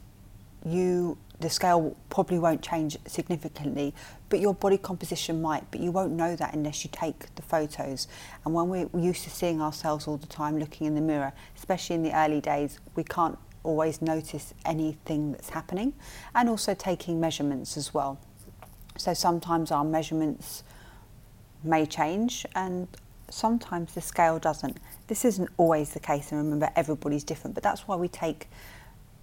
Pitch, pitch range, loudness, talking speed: 155 Hz, 145-175 Hz, -29 LUFS, 160 wpm